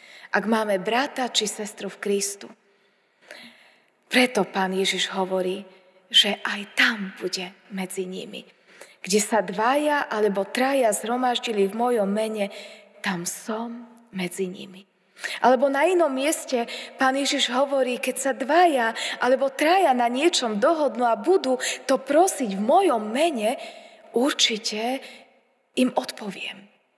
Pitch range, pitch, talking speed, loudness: 200-270 Hz, 235 Hz, 120 wpm, -23 LUFS